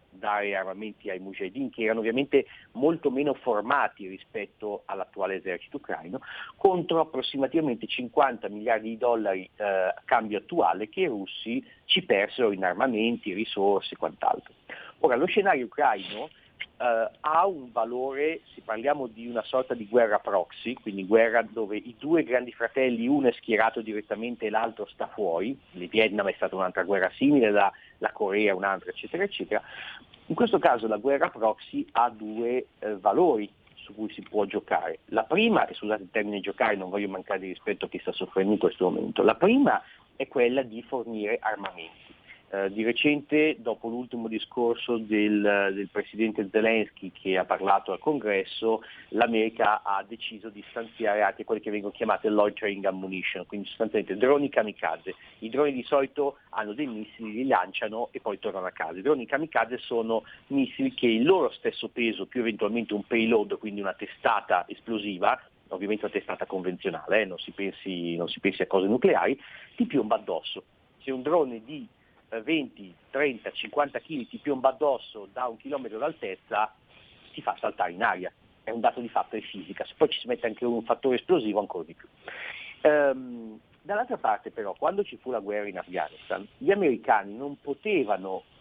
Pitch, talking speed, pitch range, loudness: 115 Hz, 170 wpm, 105-135 Hz, -27 LUFS